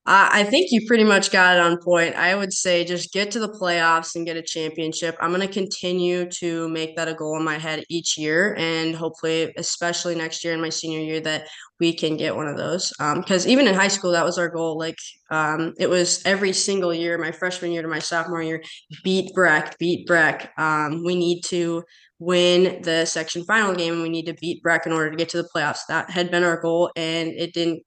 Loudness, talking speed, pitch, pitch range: -21 LUFS, 235 wpm, 170 Hz, 160-180 Hz